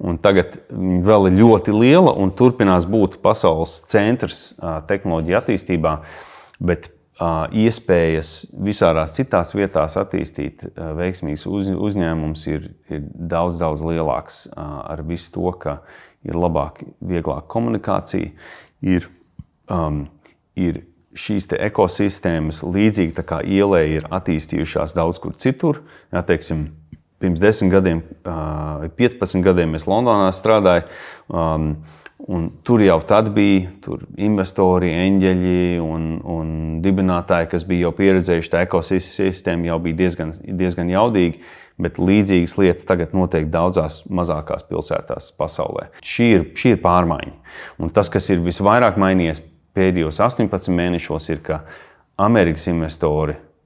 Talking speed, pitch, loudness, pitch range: 120 wpm, 90 Hz, -18 LUFS, 80-95 Hz